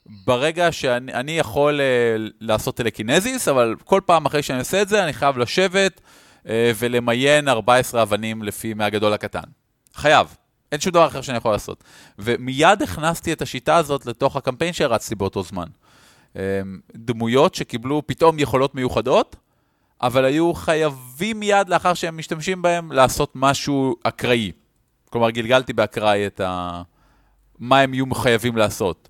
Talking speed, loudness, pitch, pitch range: 135 wpm, -20 LUFS, 130 Hz, 115-155 Hz